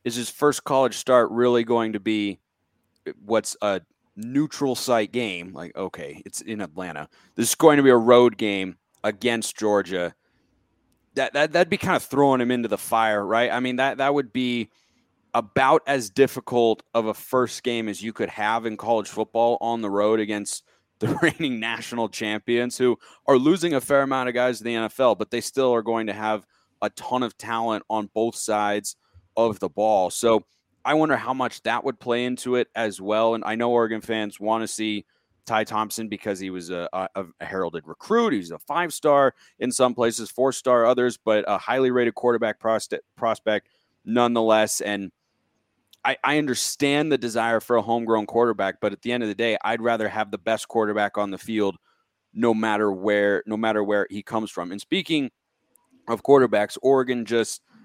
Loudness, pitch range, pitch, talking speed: -23 LUFS, 105-125 Hz, 115 Hz, 190 wpm